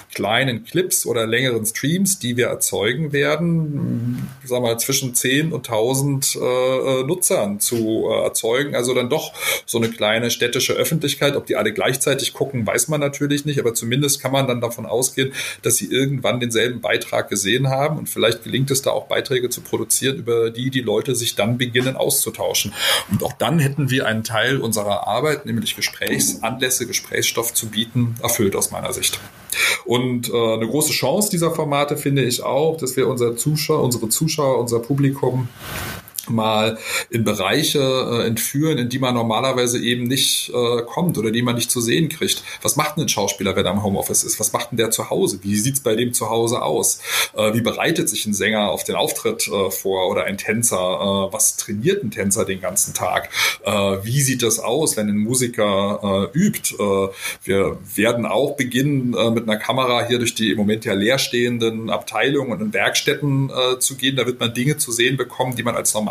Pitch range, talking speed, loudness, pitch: 115-135 Hz, 195 wpm, -19 LUFS, 125 Hz